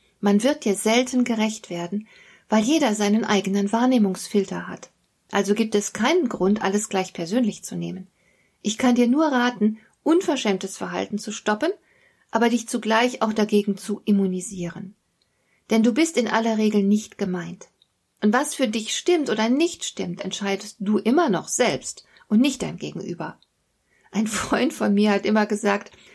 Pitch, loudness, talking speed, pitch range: 215 Hz, -22 LUFS, 160 wpm, 200-245 Hz